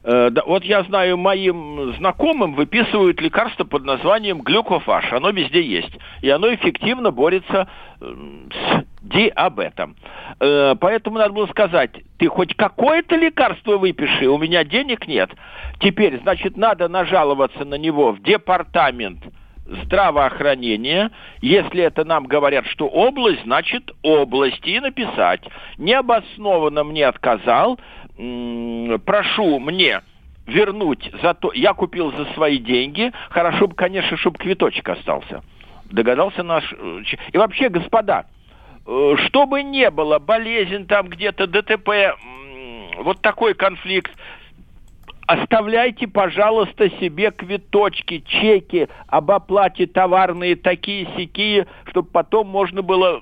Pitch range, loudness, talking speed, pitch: 160-215 Hz, -18 LUFS, 110 wpm, 190 Hz